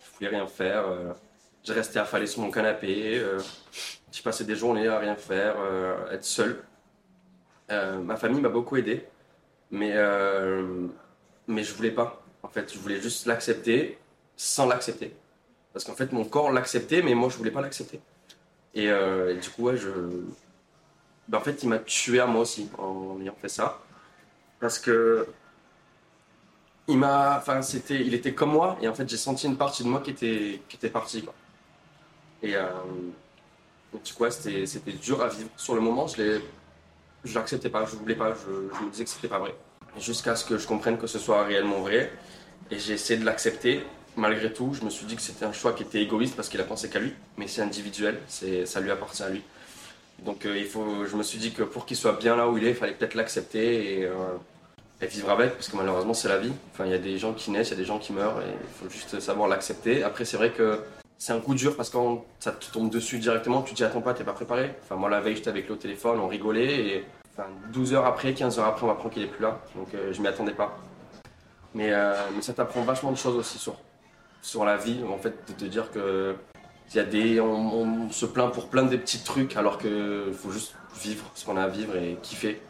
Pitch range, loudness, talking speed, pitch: 100-120 Hz, -28 LUFS, 235 wpm, 110 Hz